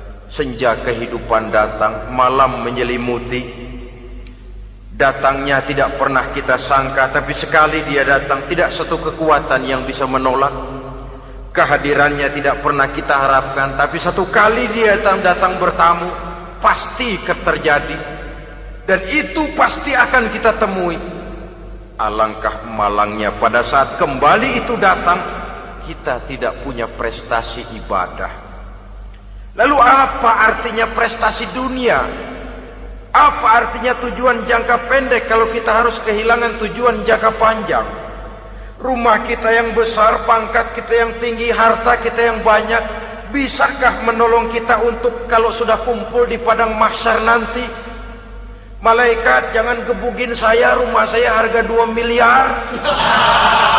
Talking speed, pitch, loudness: 115 wpm, 175 Hz, -15 LUFS